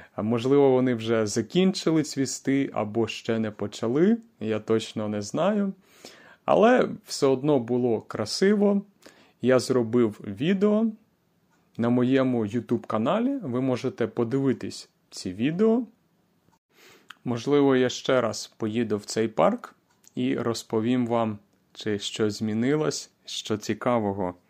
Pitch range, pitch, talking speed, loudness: 110-150 Hz, 125 Hz, 110 wpm, -25 LUFS